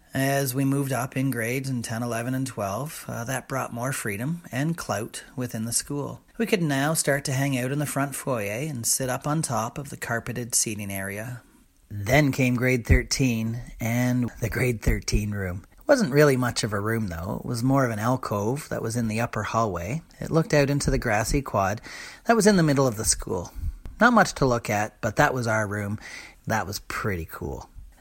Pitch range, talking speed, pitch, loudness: 110-140 Hz, 215 wpm, 125 Hz, -25 LUFS